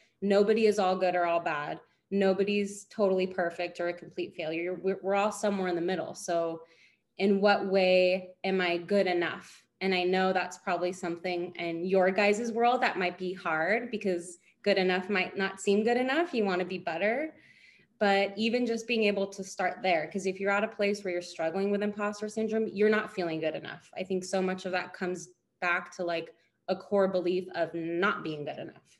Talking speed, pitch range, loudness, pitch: 205 wpm, 180-205 Hz, -29 LUFS, 185 Hz